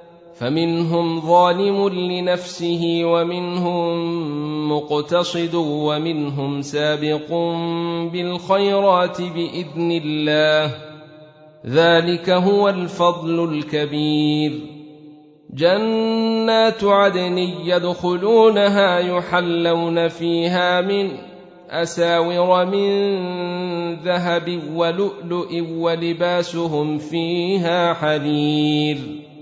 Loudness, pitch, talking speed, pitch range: -19 LUFS, 170 Hz, 55 wpm, 155-180 Hz